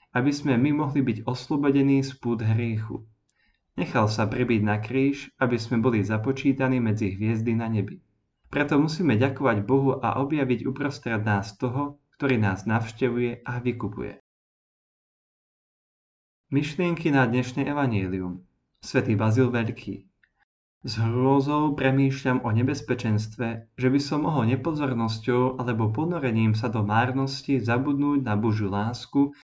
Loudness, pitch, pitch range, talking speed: -25 LUFS, 125 Hz, 110-140 Hz, 125 wpm